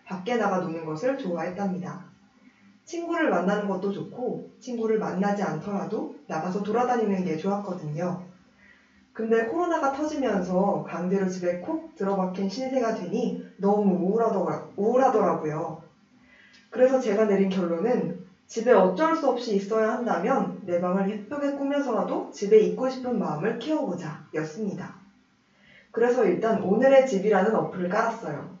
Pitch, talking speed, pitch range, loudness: 205 Hz, 320 characters per minute, 185-240 Hz, -26 LUFS